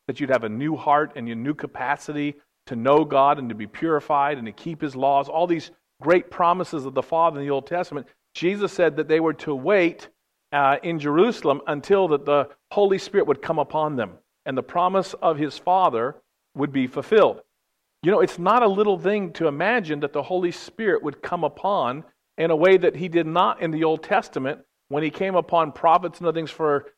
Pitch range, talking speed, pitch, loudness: 145-180 Hz, 215 wpm, 160 Hz, -22 LUFS